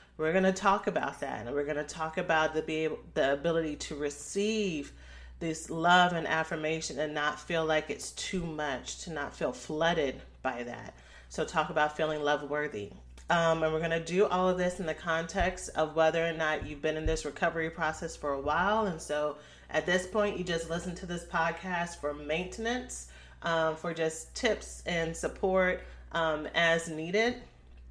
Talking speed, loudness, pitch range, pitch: 185 wpm, -31 LUFS, 150-175 Hz, 160 Hz